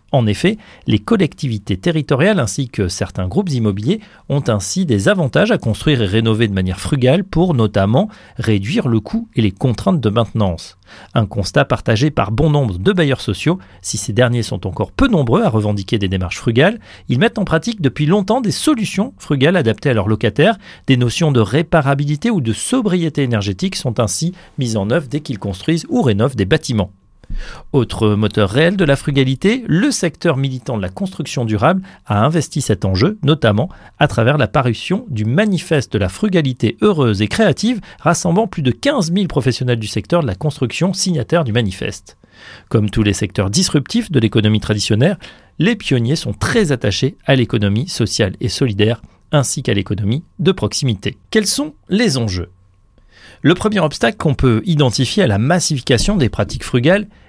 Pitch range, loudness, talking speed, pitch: 110-170 Hz, -16 LUFS, 175 wpm, 130 Hz